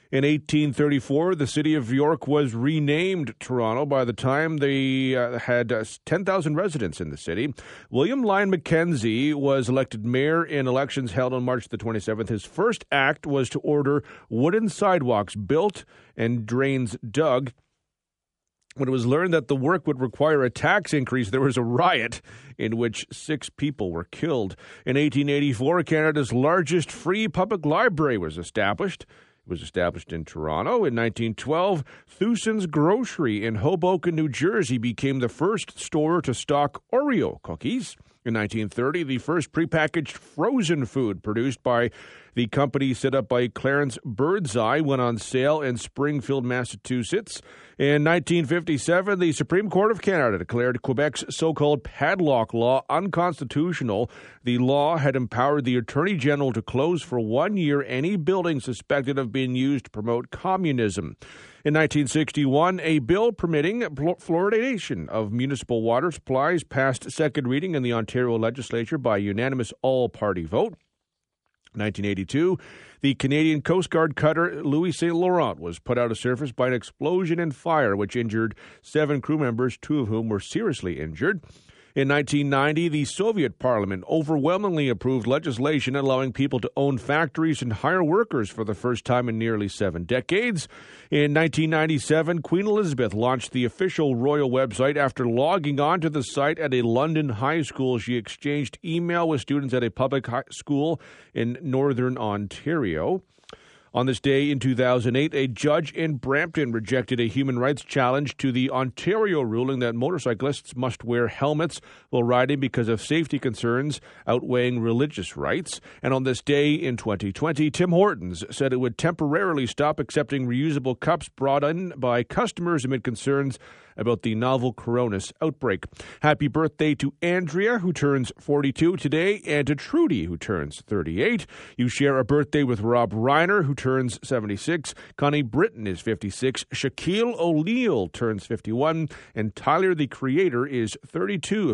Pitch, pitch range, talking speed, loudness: 135 Hz, 120-155 Hz, 150 wpm, -24 LUFS